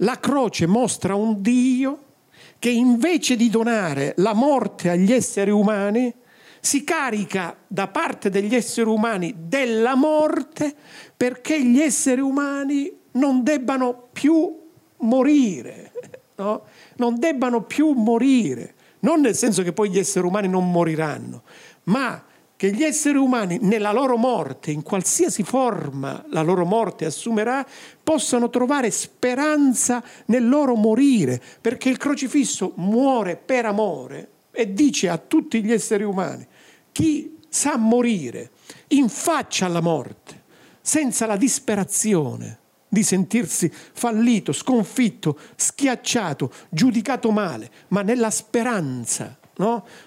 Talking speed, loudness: 120 wpm, -21 LUFS